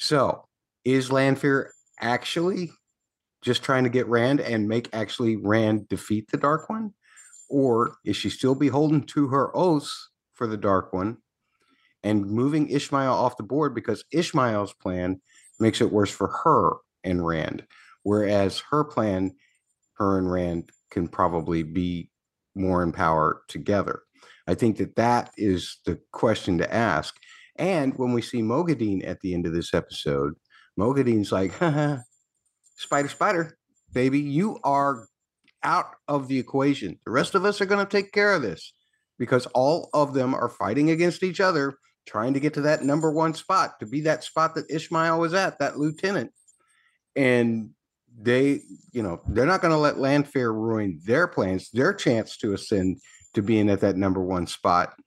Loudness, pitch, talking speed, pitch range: -24 LUFS, 125 Hz, 165 wpm, 100-150 Hz